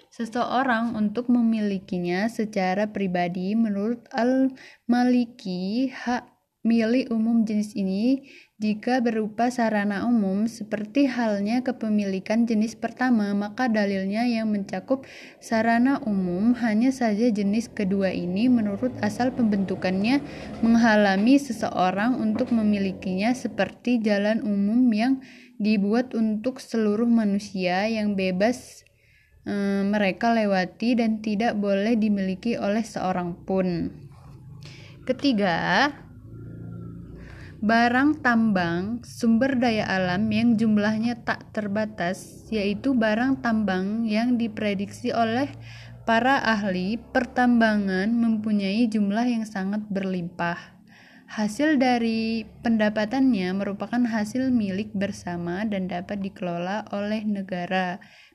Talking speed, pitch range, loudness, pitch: 95 wpm, 195-235 Hz, -24 LUFS, 215 Hz